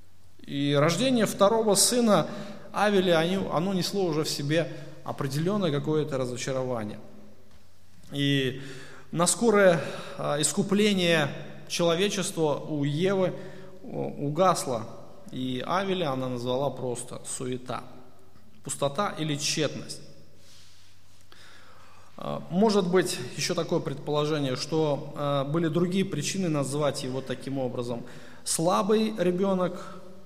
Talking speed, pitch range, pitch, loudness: 90 wpm, 130-185 Hz, 150 Hz, -27 LUFS